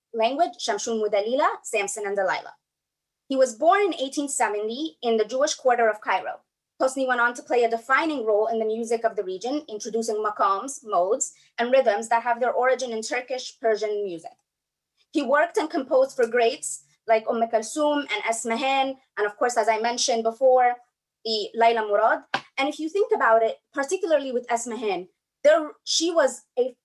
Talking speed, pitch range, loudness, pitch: 175 wpm, 225-275 Hz, -24 LUFS, 240 Hz